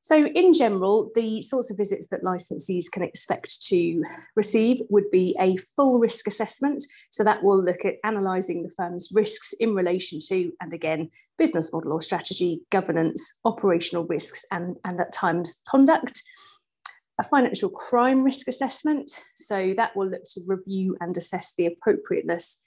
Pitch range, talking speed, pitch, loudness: 180-265 Hz, 160 wpm, 200 Hz, -24 LUFS